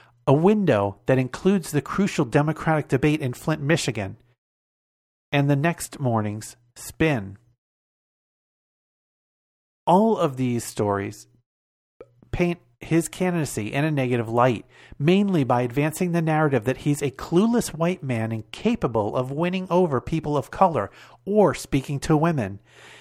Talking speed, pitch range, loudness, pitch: 130 wpm, 120-170 Hz, -23 LUFS, 140 Hz